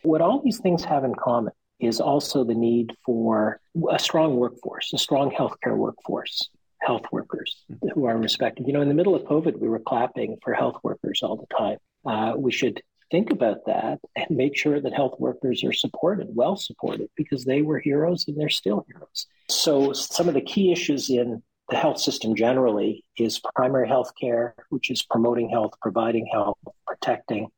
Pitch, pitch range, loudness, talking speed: 135 Hz, 115-155 Hz, -24 LUFS, 185 wpm